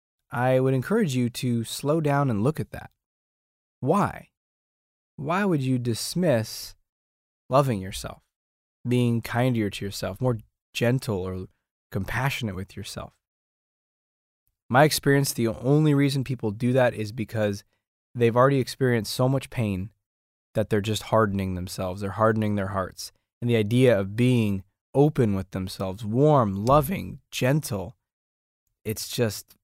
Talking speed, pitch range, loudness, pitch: 135 wpm, 100-130 Hz, -25 LUFS, 110 Hz